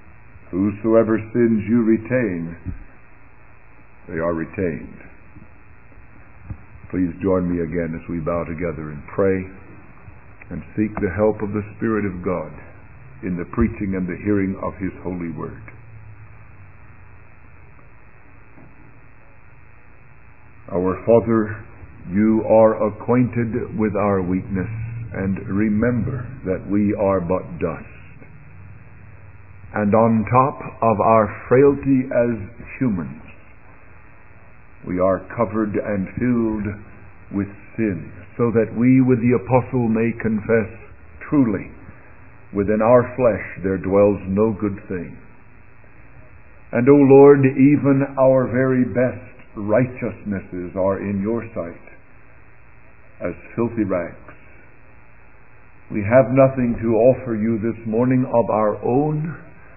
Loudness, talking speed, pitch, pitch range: -19 LUFS, 110 wpm, 110 Hz, 95-120 Hz